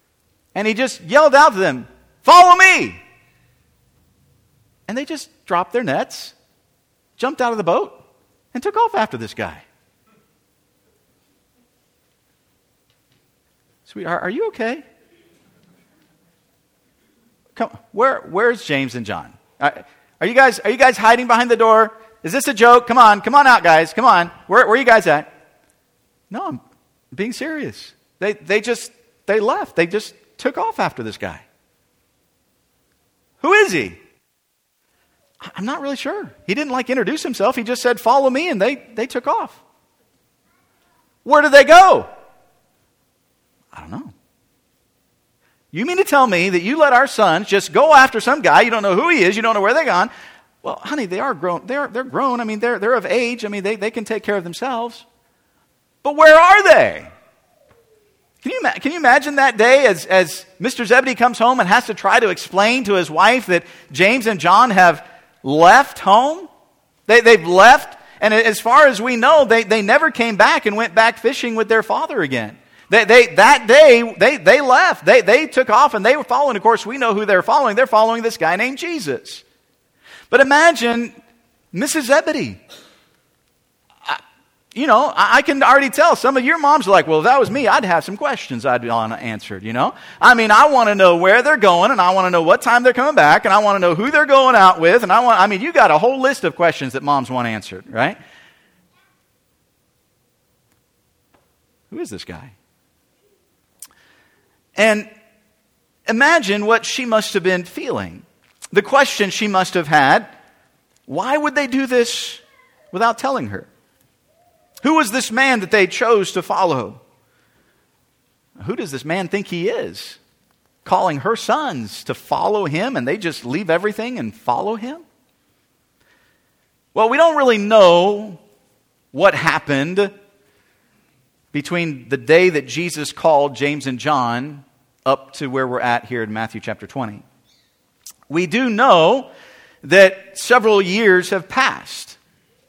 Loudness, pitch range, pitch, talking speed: -14 LUFS, 185-265 Hz, 225 Hz, 170 wpm